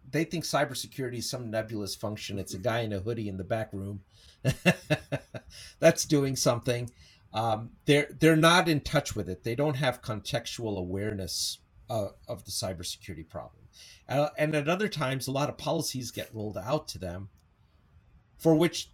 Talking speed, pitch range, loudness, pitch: 170 wpm, 100-145 Hz, -29 LUFS, 115 Hz